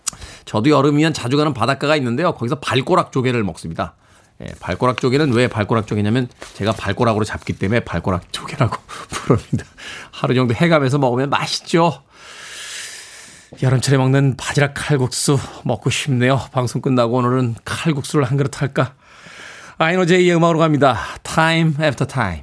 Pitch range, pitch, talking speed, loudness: 115-150 Hz, 130 Hz, 365 characters per minute, -18 LUFS